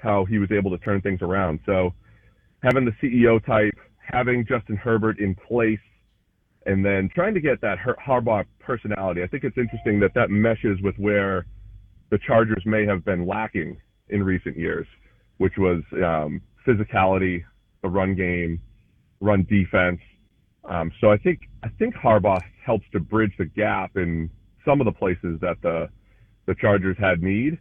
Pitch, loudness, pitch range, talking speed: 100 Hz, -23 LUFS, 95-110 Hz, 165 wpm